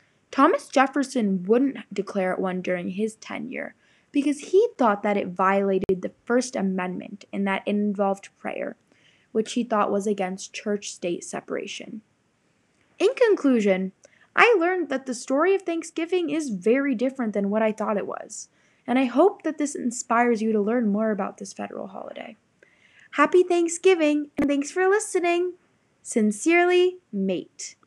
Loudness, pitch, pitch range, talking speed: -24 LUFS, 245 Hz, 205-325 Hz, 155 wpm